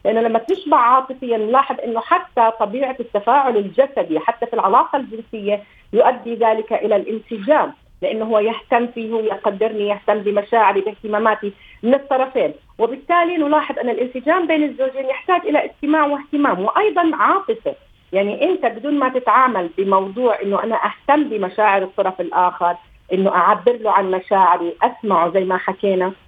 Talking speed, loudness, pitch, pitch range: 140 wpm, -18 LUFS, 230 Hz, 205-270 Hz